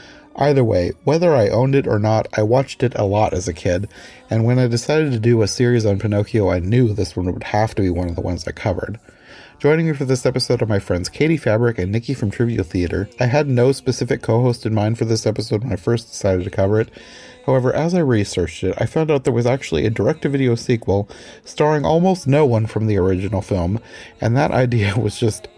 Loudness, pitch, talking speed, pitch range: -18 LUFS, 115 Hz, 240 wpm, 100-130 Hz